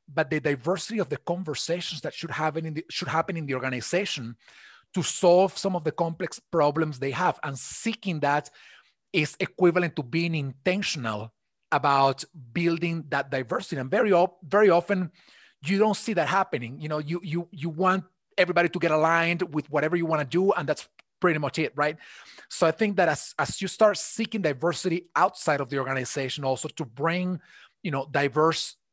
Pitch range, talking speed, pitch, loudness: 145-180 Hz, 185 wpm, 165 Hz, -26 LUFS